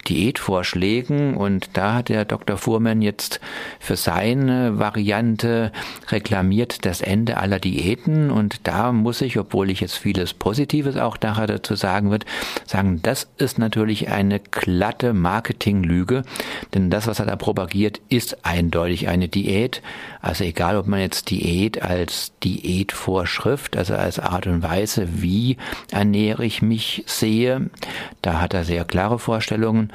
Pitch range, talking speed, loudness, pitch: 95-115 Hz, 140 wpm, -21 LUFS, 105 Hz